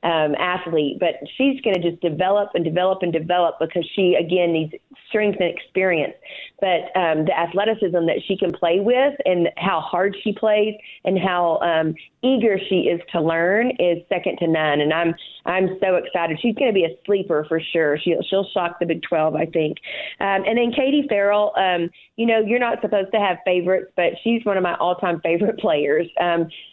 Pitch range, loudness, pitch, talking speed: 170-205 Hz, -20 LUFS, 180 Hz, 200 wpm